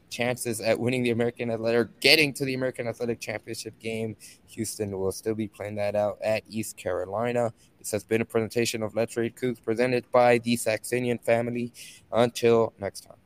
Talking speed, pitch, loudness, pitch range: 180 wpm, 115 Hz, -26 LUFS, 110-120 Hz